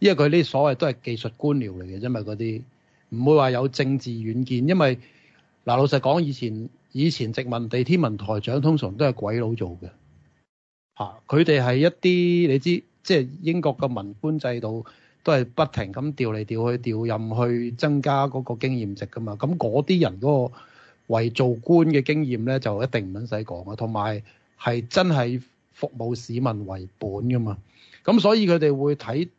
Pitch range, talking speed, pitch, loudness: 115-145 Hz, 260 characters per minute, 125 Hz, -23 LUFS